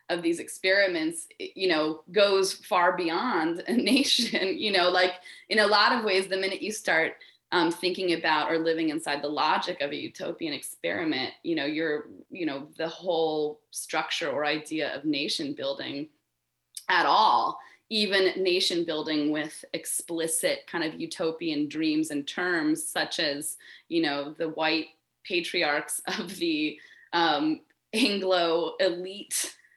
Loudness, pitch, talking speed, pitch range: -27 LUFS, 180 Hz, 145 wpm, 155-220 Hz